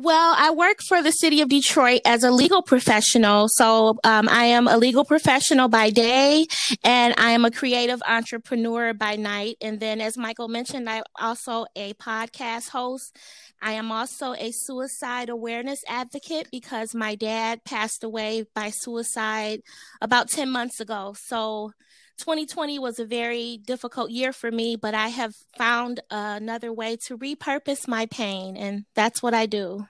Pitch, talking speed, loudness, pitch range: 235 Hz, 165 wpm, -22 LUFS, 220-260 Hz